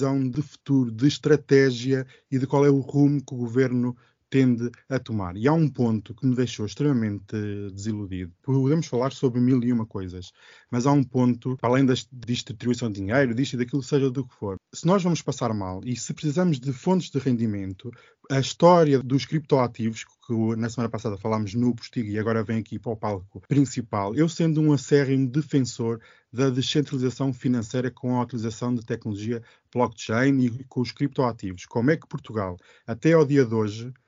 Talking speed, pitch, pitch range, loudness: 190 wpm, 125 Hz, 115-140 Hz, -24 LUFS